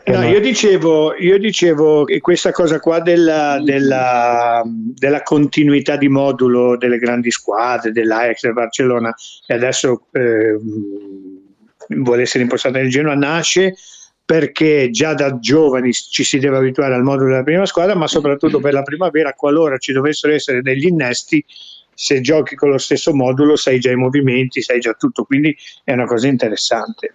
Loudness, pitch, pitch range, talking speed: -14 LUFS, 140 Hz, 125-155 Hz, 160 wpm